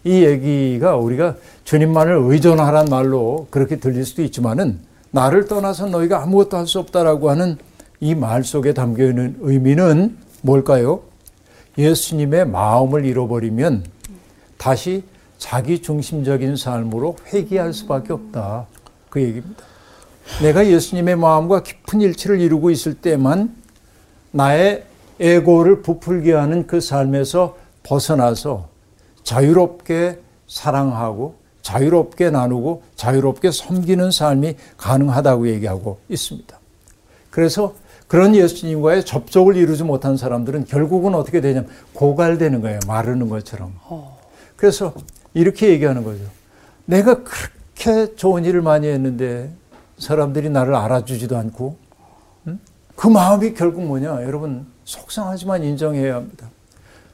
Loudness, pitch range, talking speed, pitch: -17 LUFS, 125-175 Hz, 295 characters per minute, 145 Hz